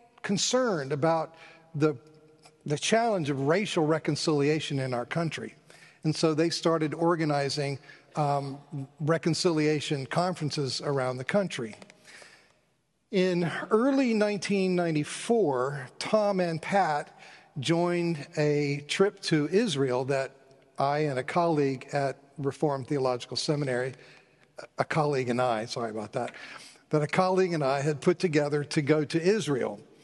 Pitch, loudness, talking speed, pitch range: 155 Hz, -28 LUFS, 120 wpm, 140-175 Hz